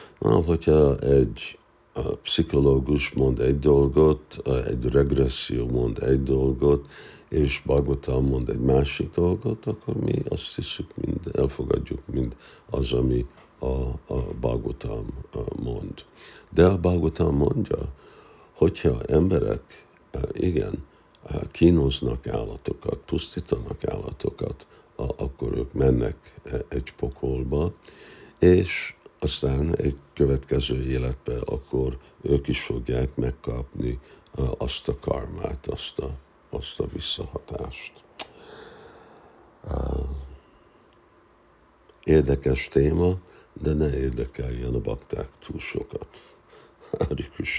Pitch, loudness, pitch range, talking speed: 70 Hz, -25 LUFS, 65-75 Hz, 95 wpm